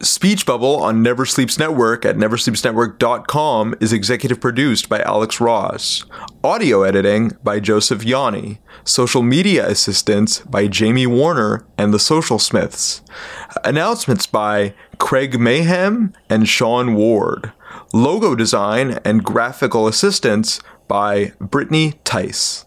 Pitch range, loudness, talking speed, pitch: 105-135 Hz, -16 LUFS, 115 wpm, 115 Hz